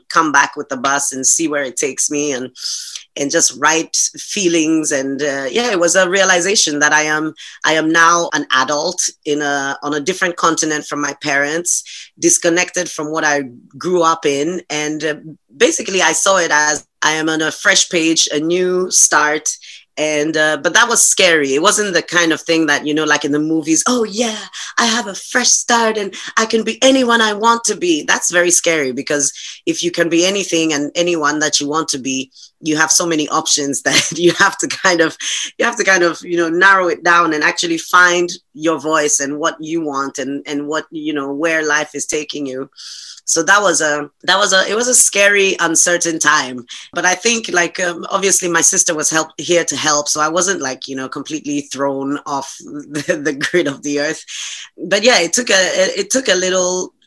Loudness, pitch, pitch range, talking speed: -14 LUFS, 160 Hz, 150-180 Hz, 215 wpm